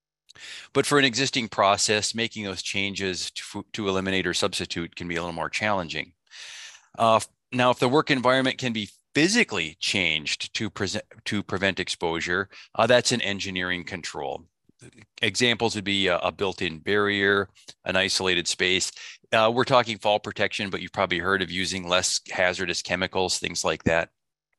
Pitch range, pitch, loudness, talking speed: 90-110 Hz, 100 Hz, -24 LUFS, 165 wpm